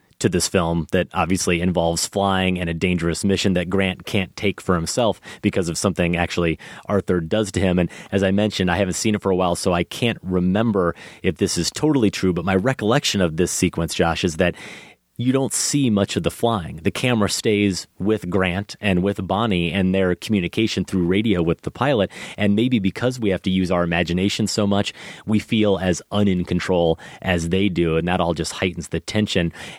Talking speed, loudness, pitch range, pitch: 205 wpm, -21 LUFS, 85-105 Hz, 95 Hz